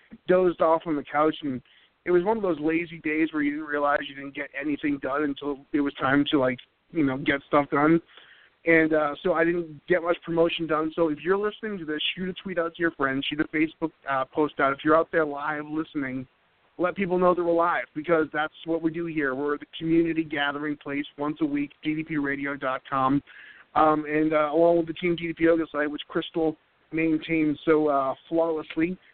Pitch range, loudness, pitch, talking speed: 145-165 Hz, -26 LUFS, 155 Hz, 215 wpm